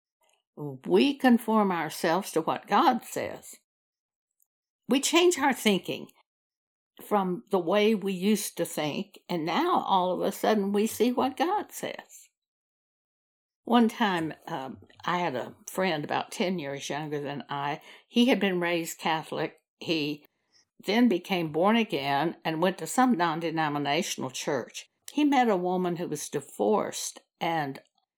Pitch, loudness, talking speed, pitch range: 185 Hz, -27 LUFS, 145 wpm, 160-230 Hz